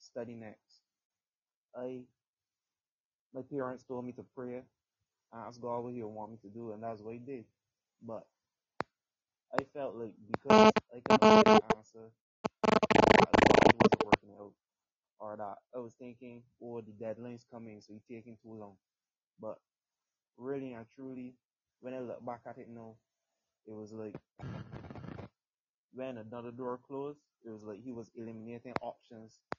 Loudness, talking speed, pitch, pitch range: -29 LUFS, 155 wpm, 120 Hz, 110-125 Hz